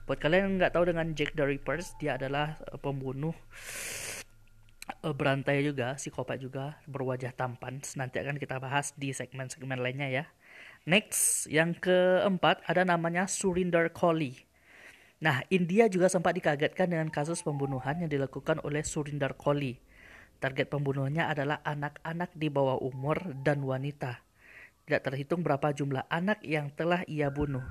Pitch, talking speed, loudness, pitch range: 145 Hz, 140 wpm, -31 LUFS, 135-165 Hz